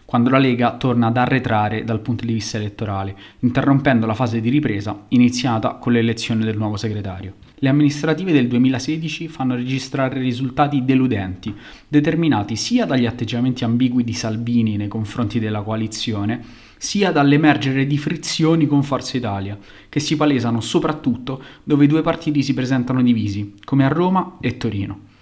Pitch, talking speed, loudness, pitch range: 125 Hz, 150 wpm, -19 LUFS, 110-140 Hz